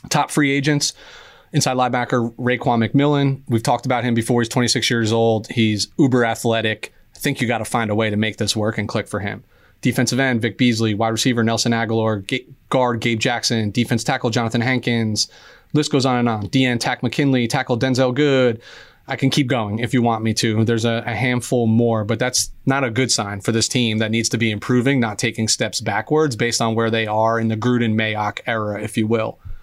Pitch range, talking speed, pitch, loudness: 110-130 Hz, 215 wpm, 120 Hz, -19 LUFS